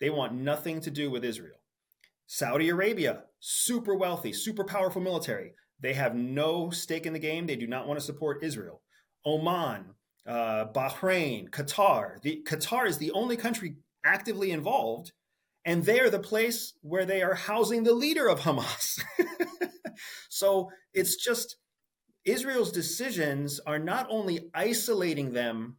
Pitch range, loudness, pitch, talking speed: 150-220 Hz, -29 LUFS, 170 Hz, 145 wpm